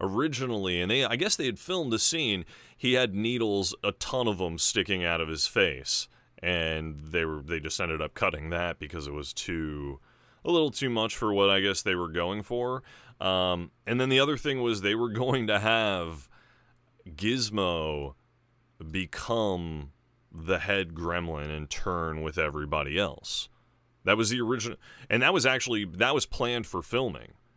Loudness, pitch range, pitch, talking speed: -28 LUFS, 80-120 Hz, 100 Hz, 175 wpm